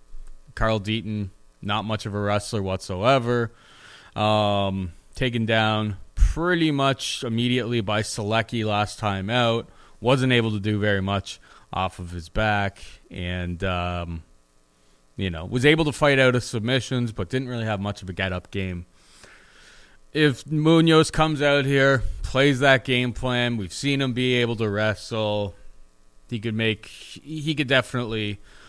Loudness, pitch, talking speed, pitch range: -23 LUFS, 110 Hz, 150 wpm, 95-125 Hz